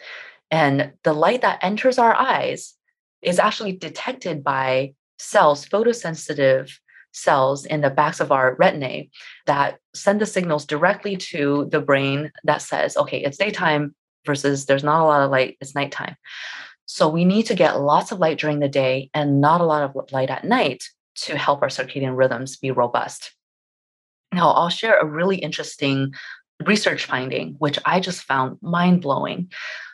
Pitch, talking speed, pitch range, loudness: 150 Hz, 165 wpm, 135-185 Hz, -20 LUFS